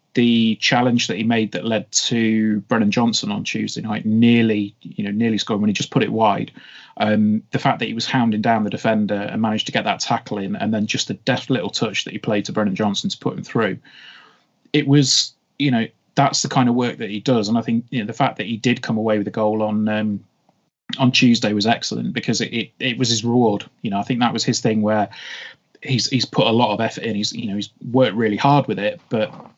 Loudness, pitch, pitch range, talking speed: -19 LUFS, 115 Hz, 105-130 Hz, 260 wpm